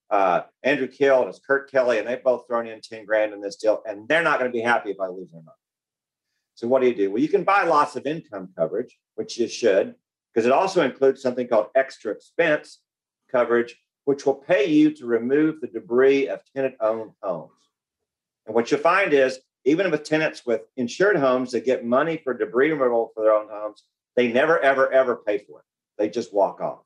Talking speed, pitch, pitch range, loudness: 215 wpm, 130 Hz, 115-140 Hz, -22 LUFS